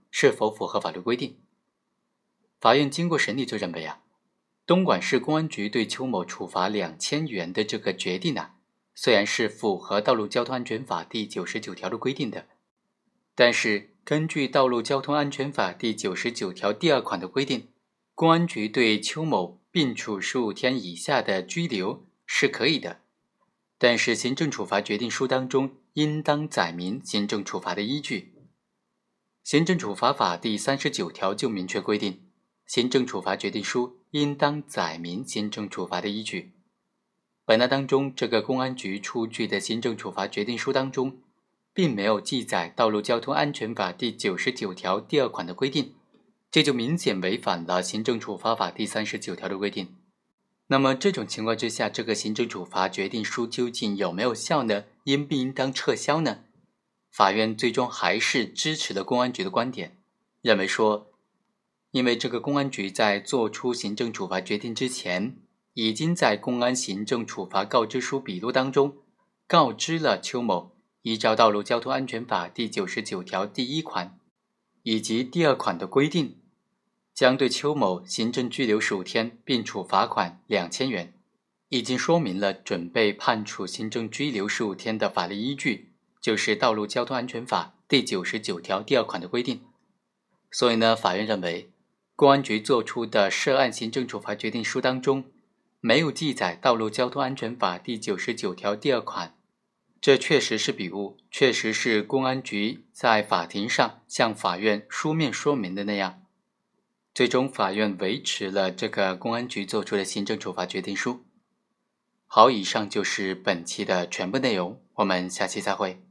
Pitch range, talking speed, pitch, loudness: 105-135 Hz, 260 characters per minute, 120 Hz, -26 LUFS